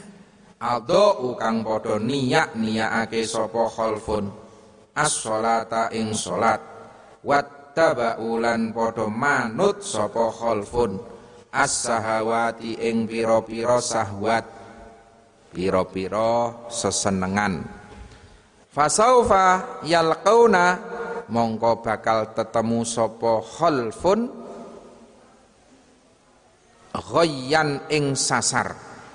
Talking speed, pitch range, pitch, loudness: 65 wpm, 110-145 Hz, 115 Hz, -22 LUFS